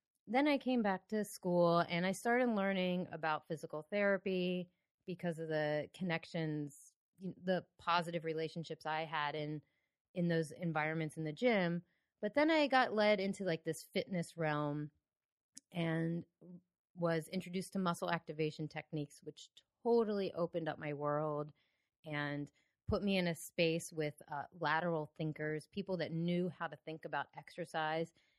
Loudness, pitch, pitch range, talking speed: -38 LUFS, 170 Hz, 155-185 Hz, 150 wpm